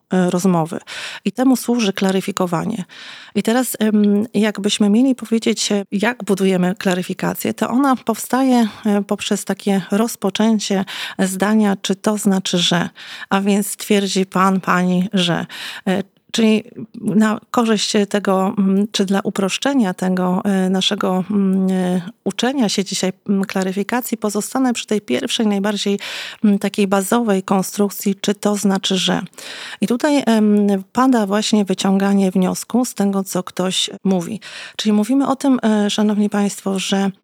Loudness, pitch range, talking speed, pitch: -18 LUFS, 190-220 Hz, 120 wpm, 205 Hz